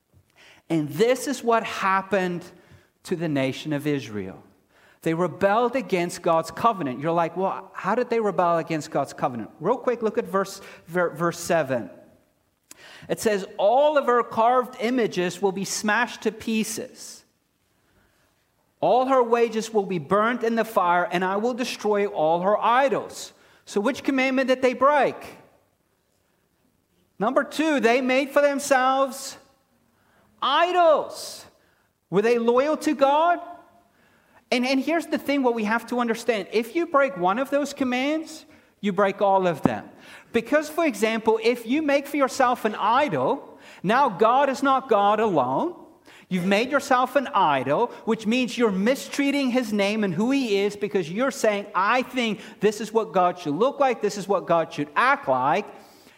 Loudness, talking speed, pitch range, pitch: -23 LUFS, 160 wpm, 190-265 Hz, 225 Hz